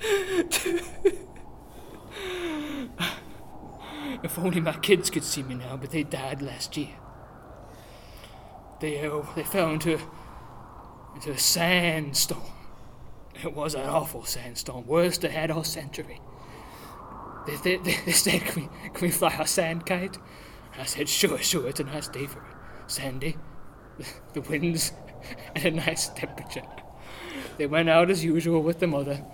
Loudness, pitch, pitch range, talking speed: -27 LUFS, 160 Hz, 140-175 Hz, 140 wpm